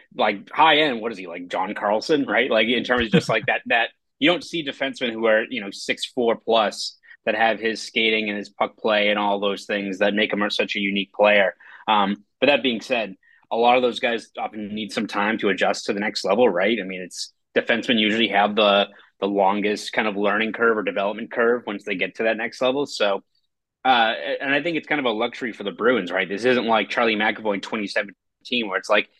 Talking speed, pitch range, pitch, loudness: 240 wpm, 100-115 Hz, 105 Hz, -21 LUFS